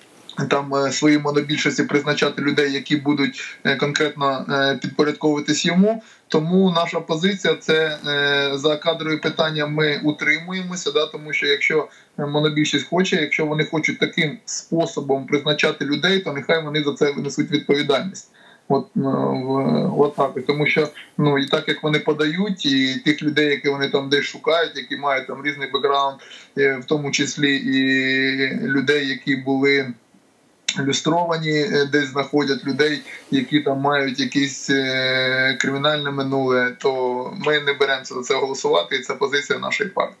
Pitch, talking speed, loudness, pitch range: 145 Hz, 135 wpm, -20 LUFS, 140-155 Hz